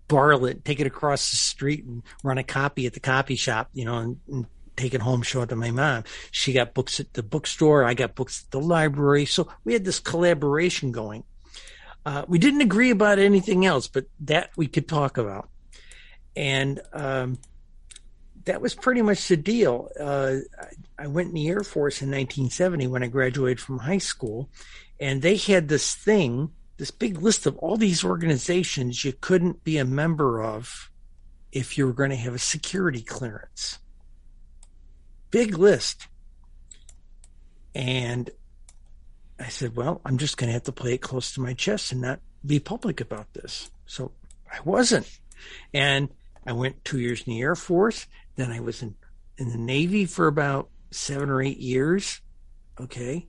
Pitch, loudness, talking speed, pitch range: 135 Hz, -24 LUFS, 180 wpm, 120-160 Hz